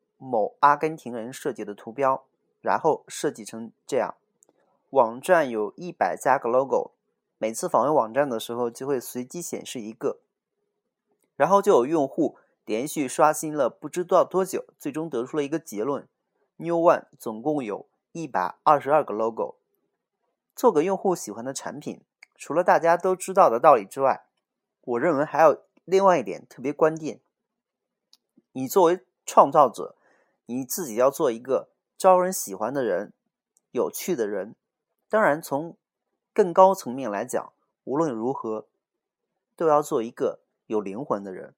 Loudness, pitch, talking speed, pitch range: -24 LUFS, 155 Hz, 245 characters per minute, 125-185 Hz